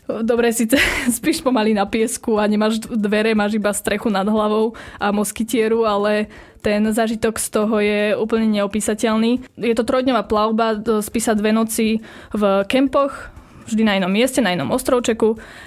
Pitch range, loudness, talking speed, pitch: 210-235 Hz, -18 LUFS, 155 wpm, 220 Hz